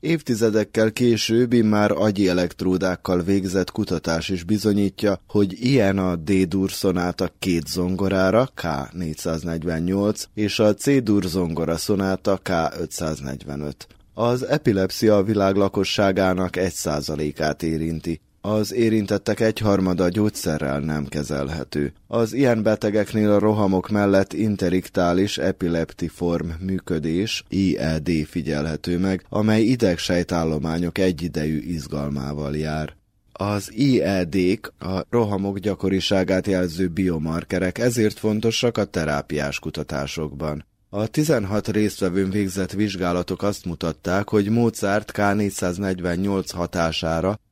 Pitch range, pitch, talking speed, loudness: 85-105 Hz, 95 Hz, 95 wpm, -22 LUFS